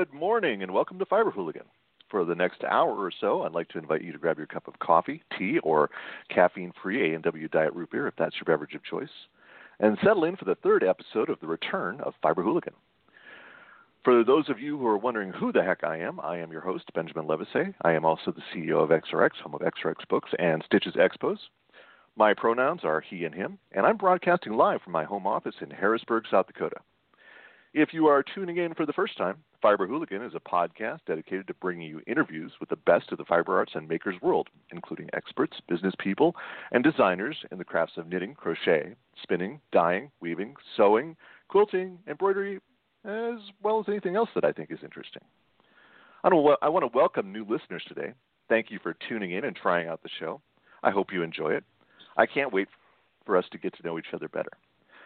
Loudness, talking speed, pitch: -27 LUFS, 210 wpm, 125 Hz